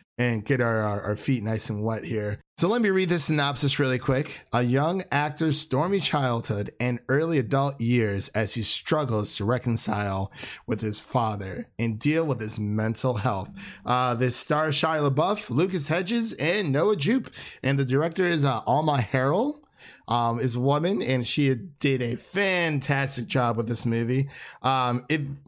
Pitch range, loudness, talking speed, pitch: 115-150 Hz, -25 LUFS, 170 wpm, 130 Hz